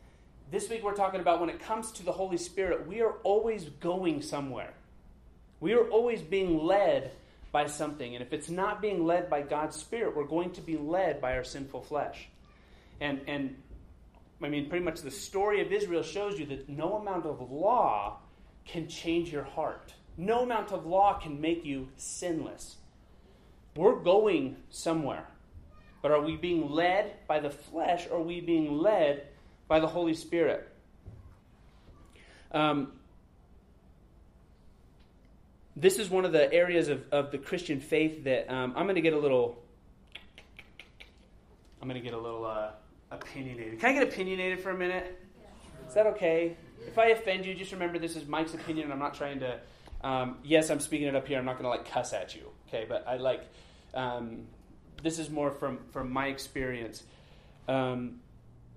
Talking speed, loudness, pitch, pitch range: 175 wpm, -31 LUFS, 150 Hz, 130-175 Hz